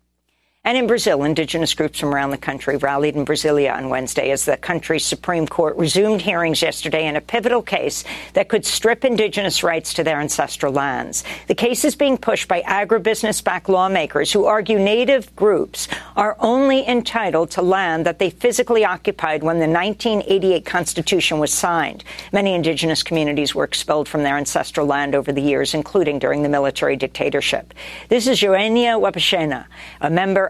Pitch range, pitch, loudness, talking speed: 150-215 Hz, 175 Hz, -18 LUFS, 165 wpm